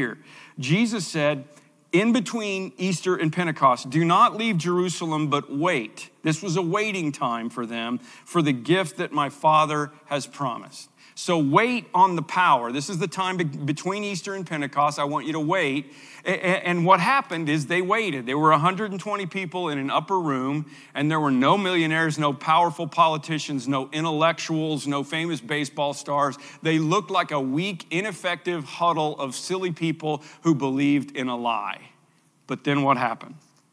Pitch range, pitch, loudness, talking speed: 145-180 Hz, 160 Hz, -24 LUFS, 165 wpm